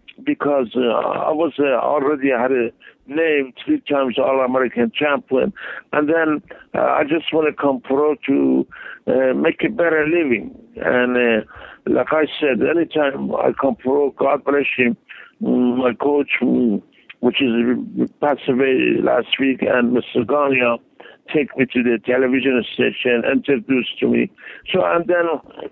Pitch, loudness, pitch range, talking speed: 135 Hz, -18 LUFS, 125-150 Hz, 150 wpm